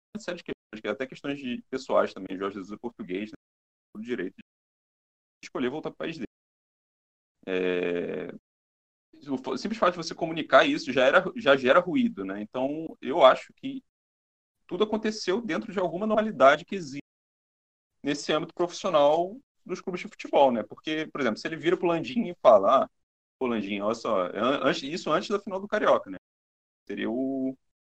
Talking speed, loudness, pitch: 175 wpm, -27 LUFS, 150 Hz